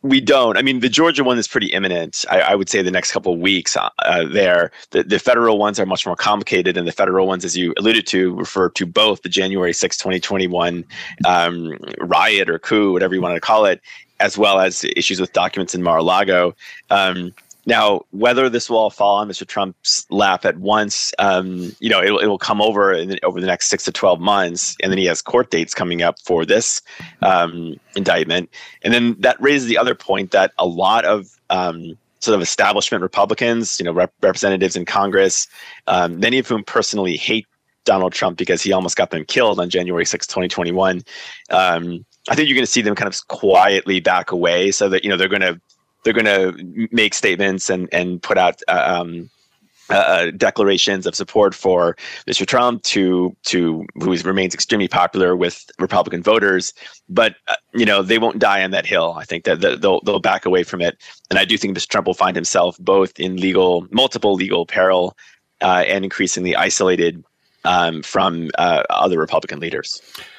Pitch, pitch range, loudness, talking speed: 95 Hz, 90-110 Hz, -17 LUFS, 200 wpm